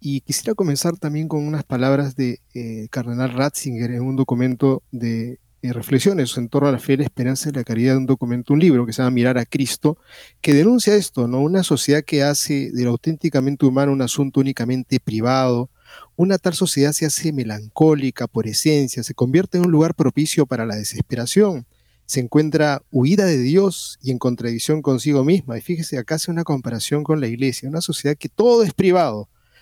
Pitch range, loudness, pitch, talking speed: 125-155 Hz, -19 LUFS, 140 Hz, 190 wpm